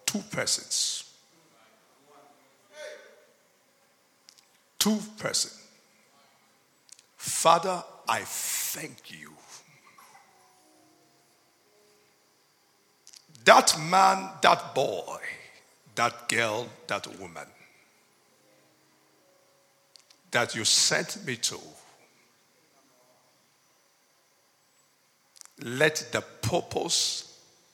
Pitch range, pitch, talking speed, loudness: 170-220 Hz, 190 Hz, 50 wpm, -26 LUFS